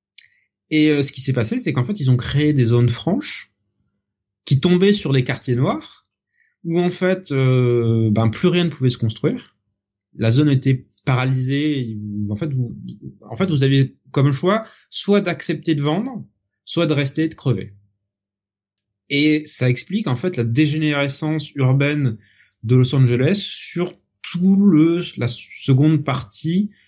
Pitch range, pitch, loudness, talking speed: 115-160 Hz, 135 Hz, -19 LUFS, 160 wpm